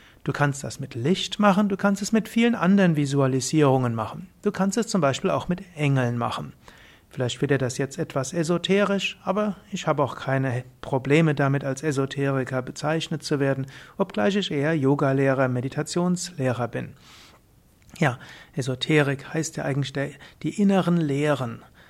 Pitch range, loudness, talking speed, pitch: 135-185 Hz, -24 LUFS, 155 wpm, 145 Hz